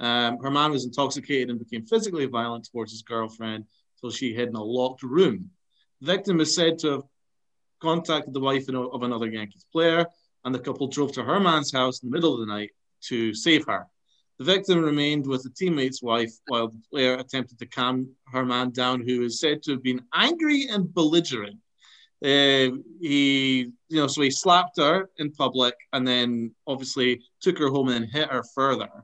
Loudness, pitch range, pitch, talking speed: -24 LUFS, 125-155 Hz, 135 Hz, 195 wpm